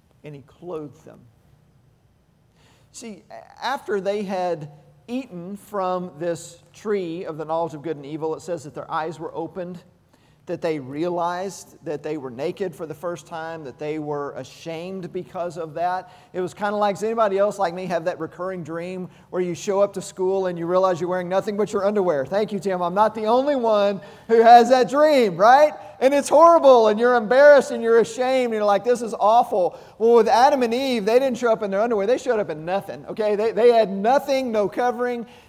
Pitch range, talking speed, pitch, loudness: 165-225 Hz, 210 wpm, 185 Hz, -20 LUFS